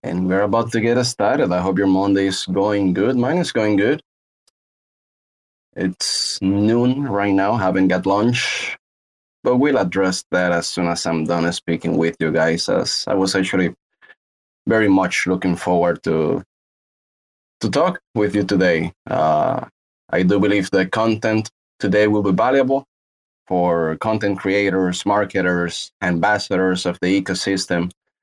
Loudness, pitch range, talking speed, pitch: -19 LUFS, 90-105 Hz, 150 wpm, 95 Hz